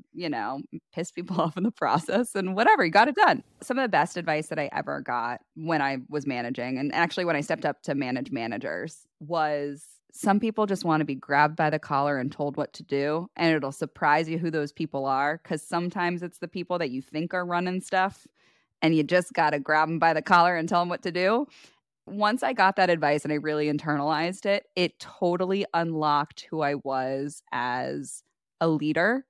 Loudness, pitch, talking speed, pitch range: -26 LUFS, 160 Hz, 215 wpm, 150-180 Hz